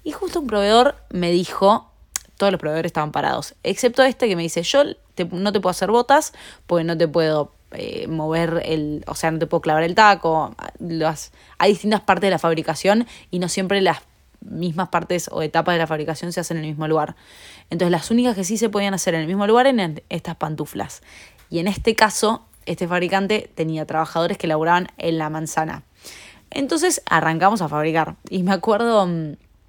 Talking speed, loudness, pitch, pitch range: 195 wpm, -20 LUFS, 175 Hz, 160-205 Hz